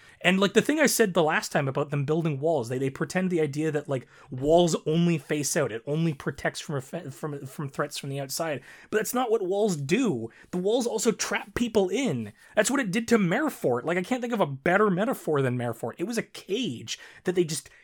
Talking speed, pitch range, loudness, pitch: 235 wpm, 145-210 Hz, -27 LUFS, 165 Hz